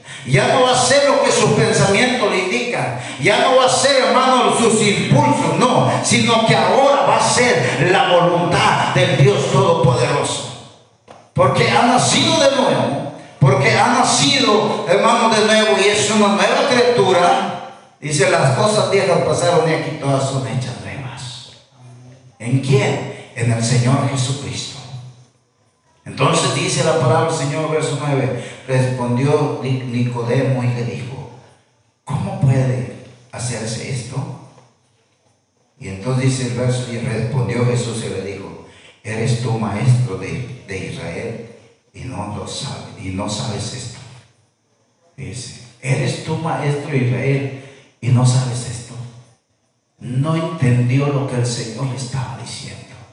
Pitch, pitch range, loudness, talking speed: 130 Hz, 120-145 Hz, -16 LUFS, 140 wpm